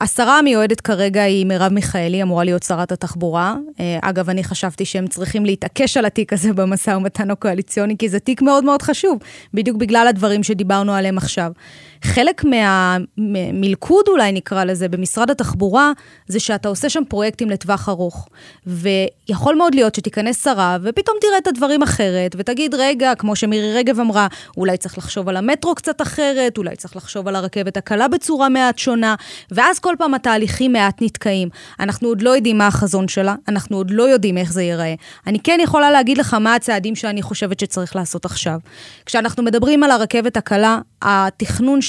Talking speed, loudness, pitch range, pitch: 170 wpm, -16 LUFS, 190-250 Hz, 210 Hz